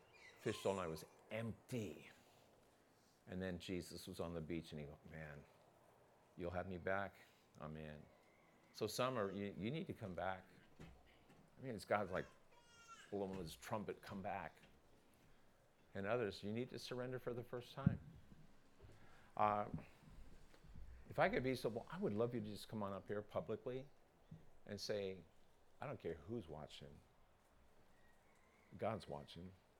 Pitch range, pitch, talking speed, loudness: 85-110 Hz, 95 Hz, 155 wpm, -47 LUFS